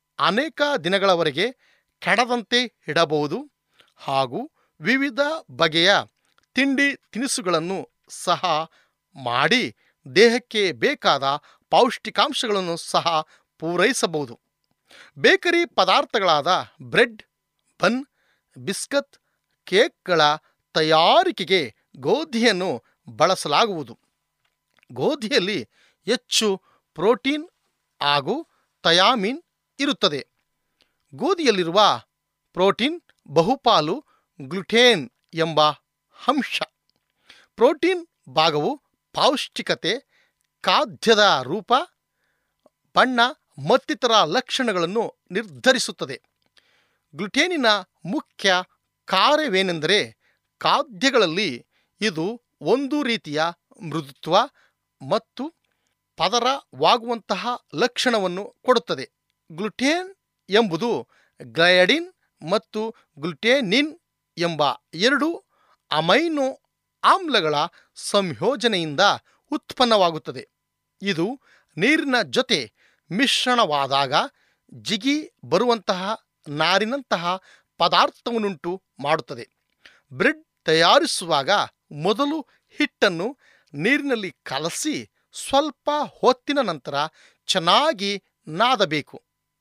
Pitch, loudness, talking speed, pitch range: 220 Hz, -21 LUFS, 60 wpm, 175-275 Hz